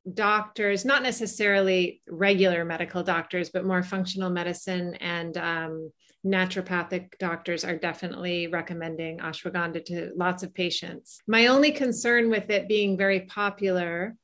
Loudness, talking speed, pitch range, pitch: -26 LUFS, 125 wpm, 170-200 Hz, 185 Hz